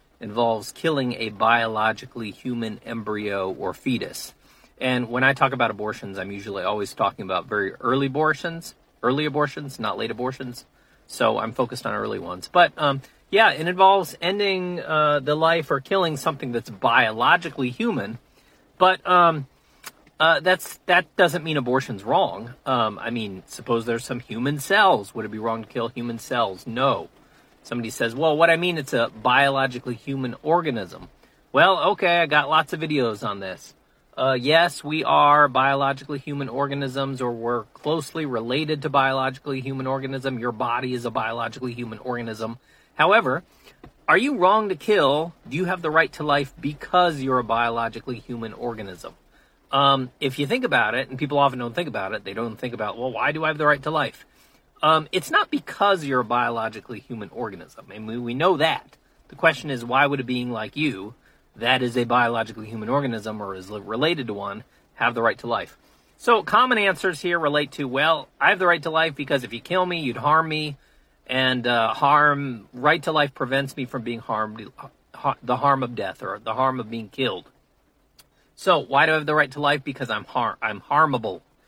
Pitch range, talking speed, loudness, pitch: 120-155 Hz, 190 wpm, -22 LUFS, 135 Hz